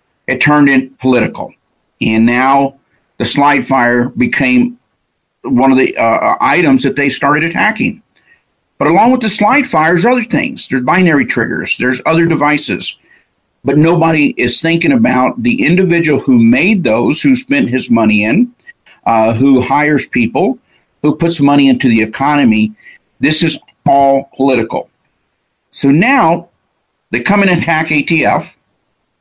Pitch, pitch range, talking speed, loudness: 150 Hz, 135-205 Hz, 140 wpm, -11 LUFS